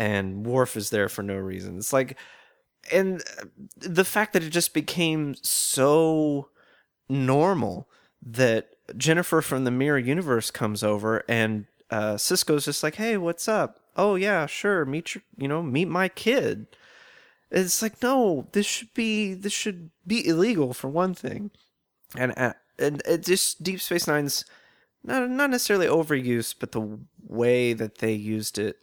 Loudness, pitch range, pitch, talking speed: -25 LUFS, 120-185 Hz, 150 Hz, 160 wpm